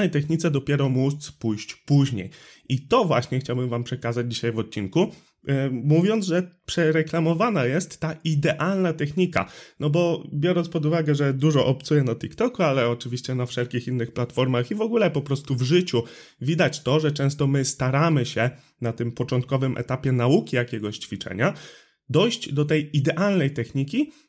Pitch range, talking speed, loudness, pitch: 125-165 Hz, 160 wpm, -24 LUFS, 140 Hz